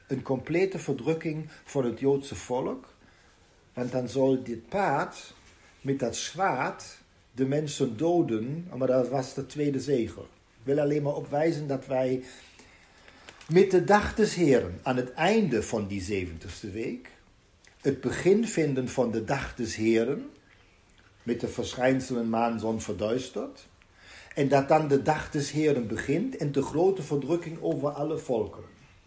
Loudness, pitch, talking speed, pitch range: -28 LUFS, 130 Hz, 150 wpm, 115-150 Hz